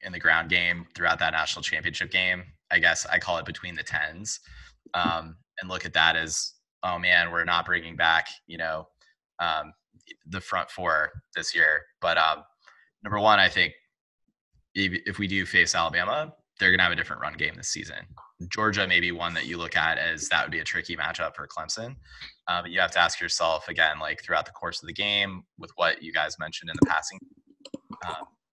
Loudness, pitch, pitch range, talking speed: -25 LUFS, 90 Hz, 85-100 Hz, 210 wpm